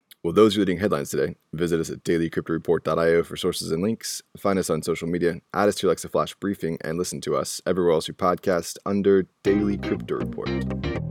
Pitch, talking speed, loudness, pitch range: 85 Hz, 200 wpm, -24 LUFS, 80-100 Hz